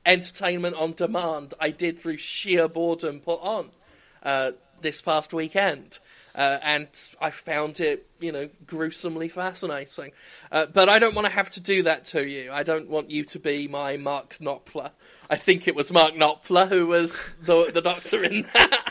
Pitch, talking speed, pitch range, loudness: 165 Hz, 180 wpm, 150-180 Hz, -24 LUFS